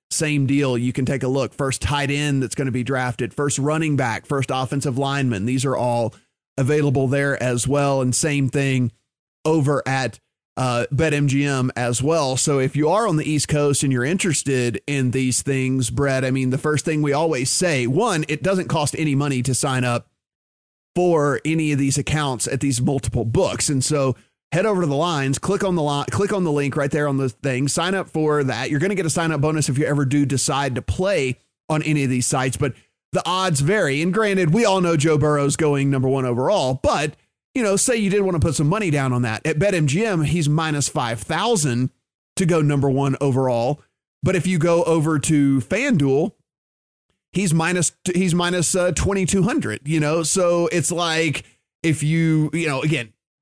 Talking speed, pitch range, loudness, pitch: 210 wpm, 130-160 Hz, -20 LUFS, 145 Hz